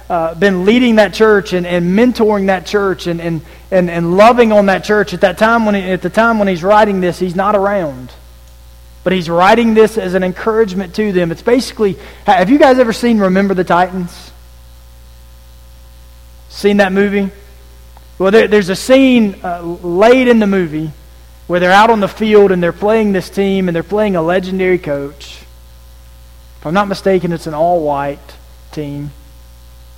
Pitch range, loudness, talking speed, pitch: 140-205 Hz, -12 LUFS, 180 wpm, 185 Hz